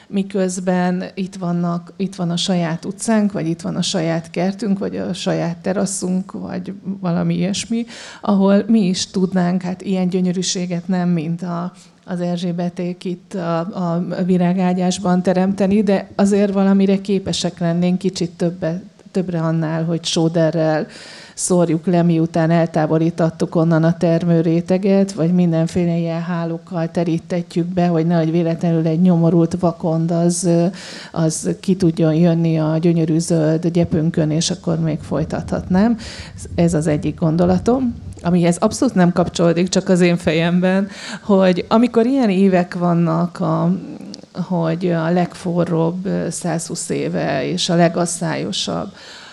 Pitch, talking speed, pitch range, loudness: 175 Hz, 130 wpm, 165-185 Hz, -18 LUFS